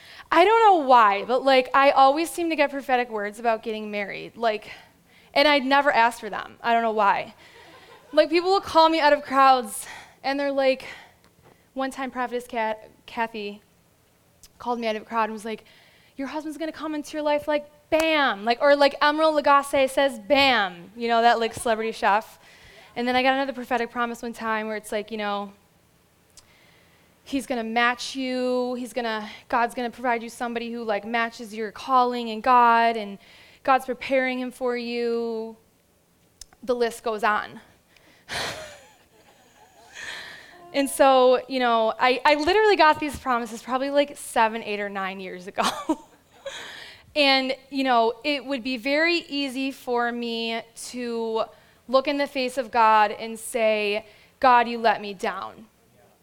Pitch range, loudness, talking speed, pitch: 225-280 Hz, -23 LUFS, 170 wpm, 245 Hz